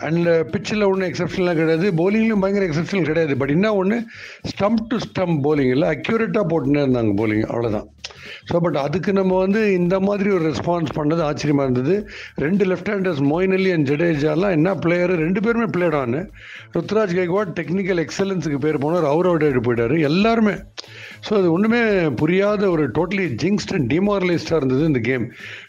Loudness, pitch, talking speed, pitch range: -19 LUFS, 175 Hz, 155 wpm, 150-195 Hz